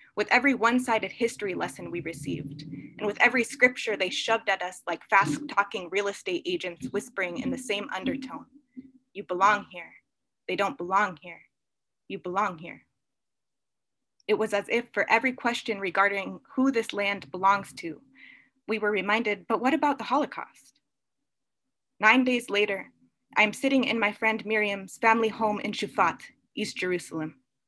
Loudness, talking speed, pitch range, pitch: -26 LUFS, 160 wpm, 195-245 Hz, 210 Hz